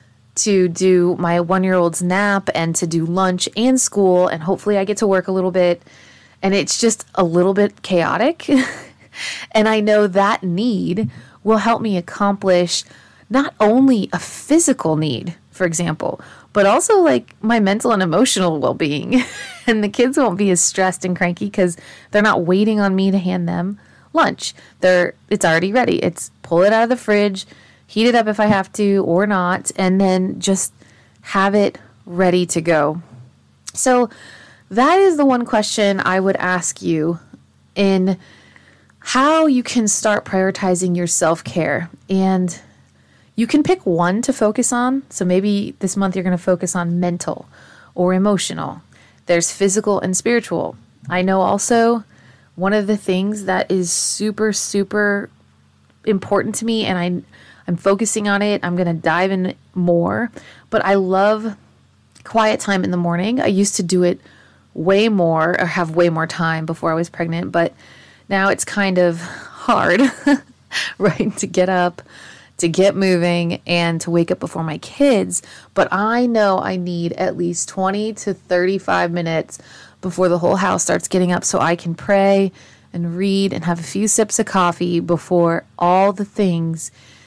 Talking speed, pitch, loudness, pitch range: 170 wpm, 190 Hz, -17 LUFS, 175-210 Hz